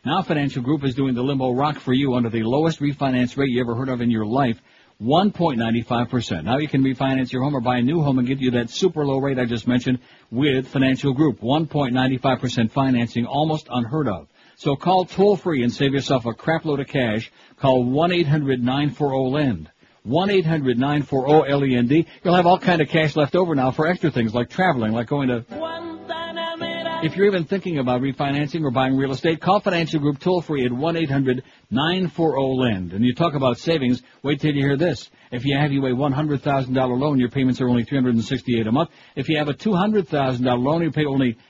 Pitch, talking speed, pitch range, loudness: 135 Hz, 190 wpm, 125-155 Hz, -21 LUFS